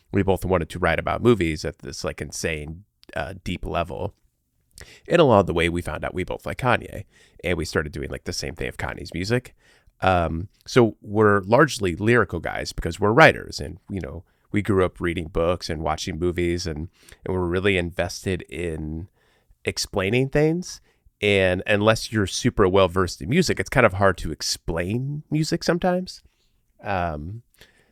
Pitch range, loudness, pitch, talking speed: 85-105 Hz, -23 LUFS, 95 Hz, 175 wpm